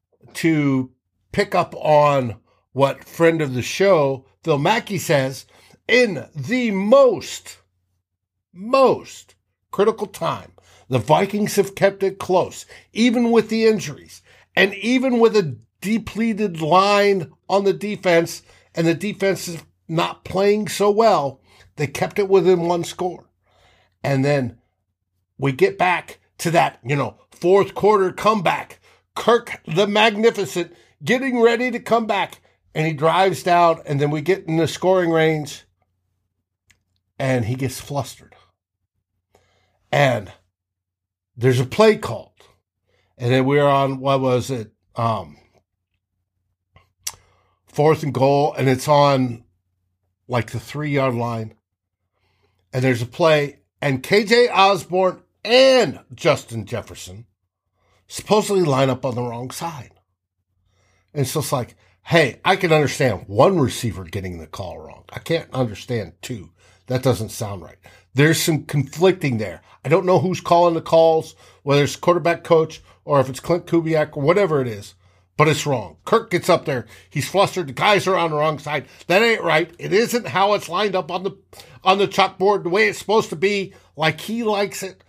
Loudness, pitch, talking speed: -19 LUFS, 145 Hz, 150 wpm